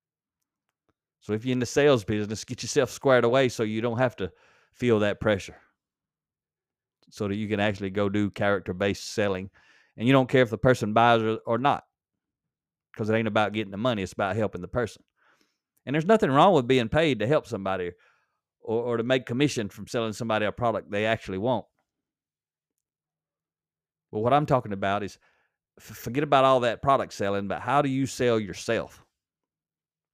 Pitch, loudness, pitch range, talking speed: 115 Hz, -25 LUFS, 100-130 Hz, 180 wpm